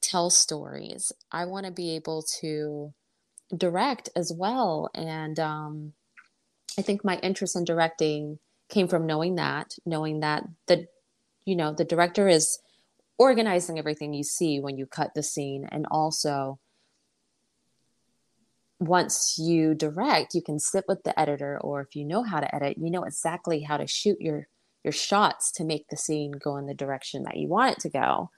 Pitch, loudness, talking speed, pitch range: 160 Hz, -27 LUFS, 170 wpm, 150-180 Hz